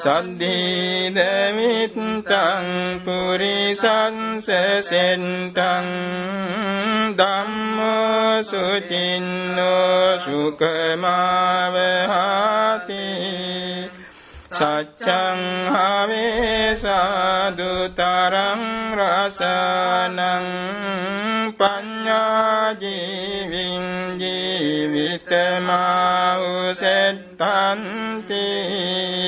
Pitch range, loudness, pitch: 180-200 Hz, -20 LUFS, 185 Hz